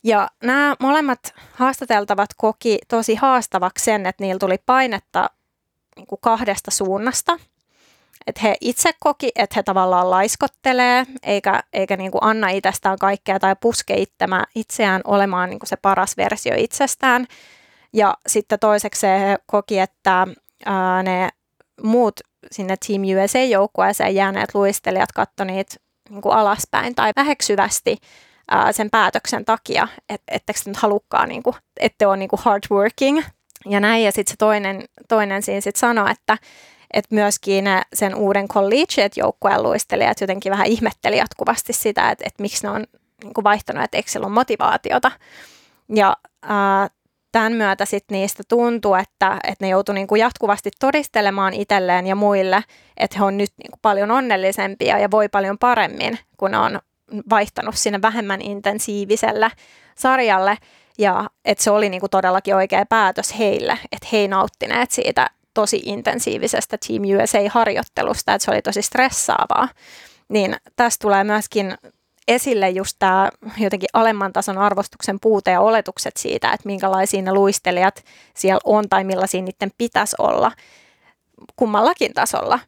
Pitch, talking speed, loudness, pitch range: 205 Hz, 140 wpm, -18 LUFS, 195-230 Hz